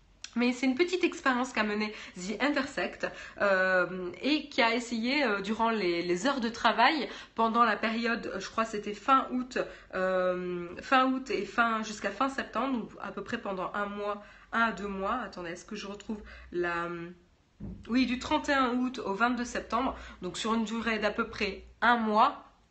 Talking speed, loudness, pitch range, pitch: 190 wpm, -30 LUFS, 200-250 Hz, 225 Hz